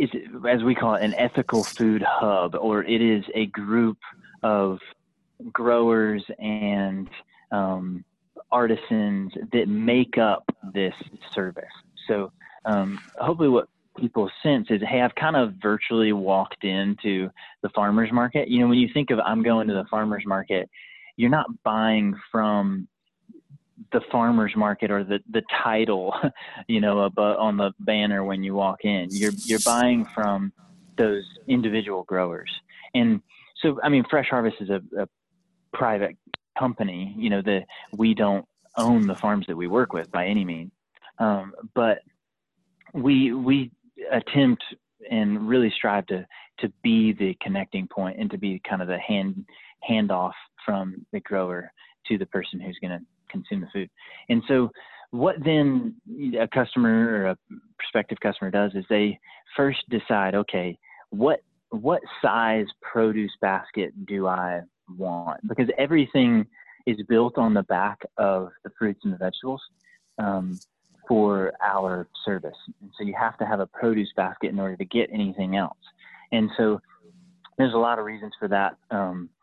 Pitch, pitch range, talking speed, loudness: 110 Hz, 100-130 Hz, 155 wpm, -24 LUFS